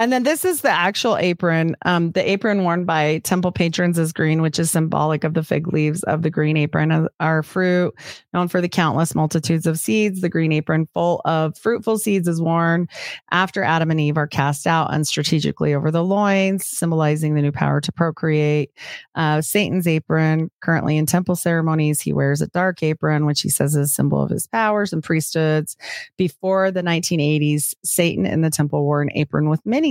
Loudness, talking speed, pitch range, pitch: -19 LUFS, 195 wpm, 155-180 Hz, 165 Hz